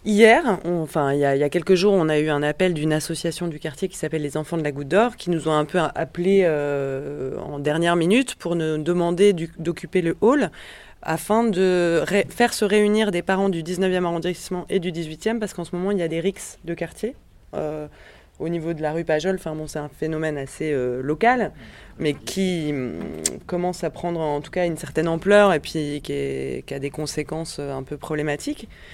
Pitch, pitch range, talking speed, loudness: 165 Hz, 150-185 Hz, 225 wpm, -22 LUFS